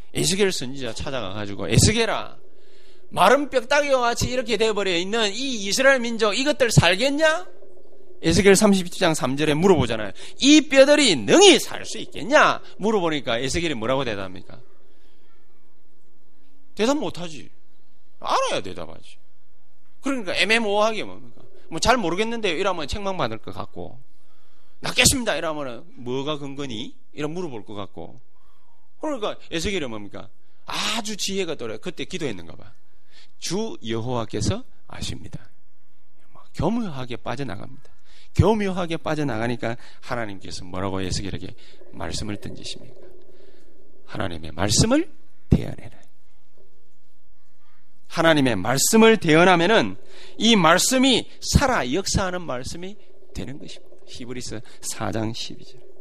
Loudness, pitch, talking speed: -21 LUFS, 165 Hz, 295 characters per minute